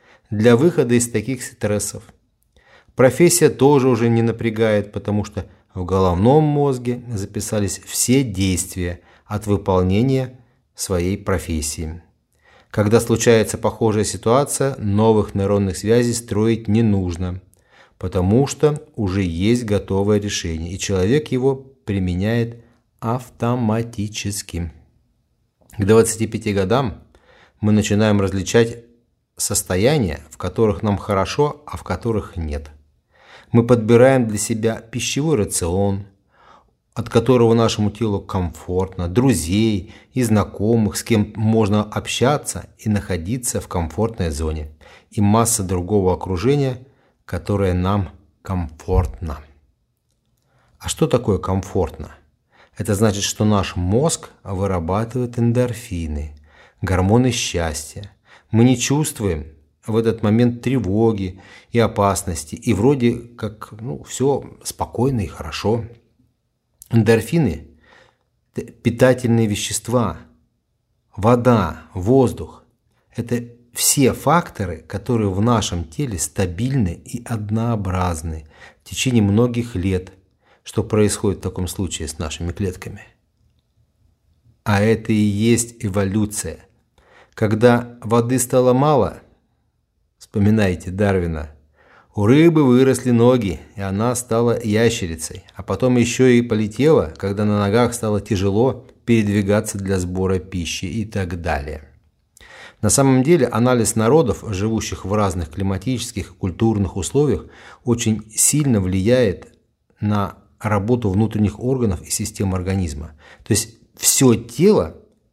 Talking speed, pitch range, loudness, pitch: 110 wpm, 95-120 Hz, -19 LUFS, 105 Hz